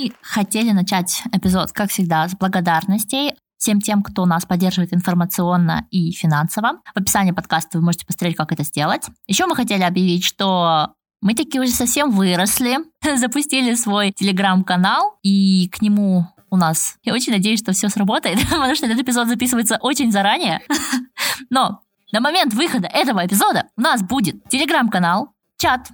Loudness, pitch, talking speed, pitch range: -18 LUFS, 200 Hz, 155 wpm, 180-245 Hz